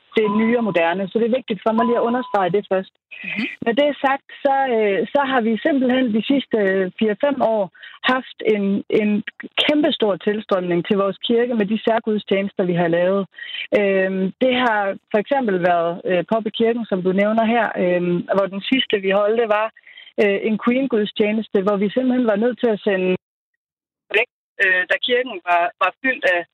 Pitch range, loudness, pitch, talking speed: 195-245 Hz, -19 LUFS, 215 Hz, 175 wpm